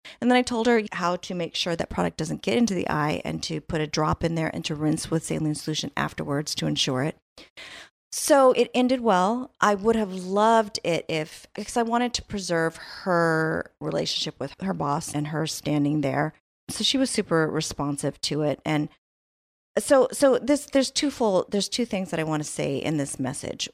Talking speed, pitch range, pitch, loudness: 205 wpm, 155-230 Hz, 170 Hz, -25 LUFS